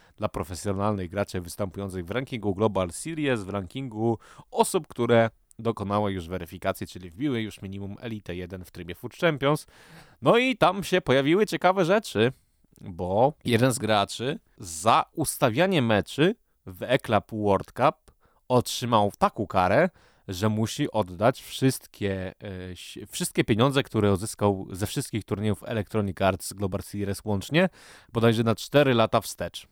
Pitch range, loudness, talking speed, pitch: 100-130 Hz, -26 LUFS, 135 wpm, 110 Hz